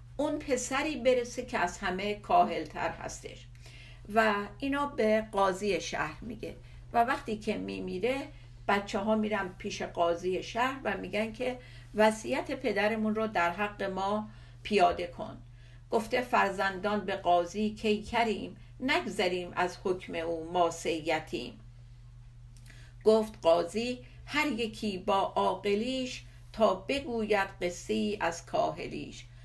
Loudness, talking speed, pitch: -31 LUFS, 120 wpm, 200 Hz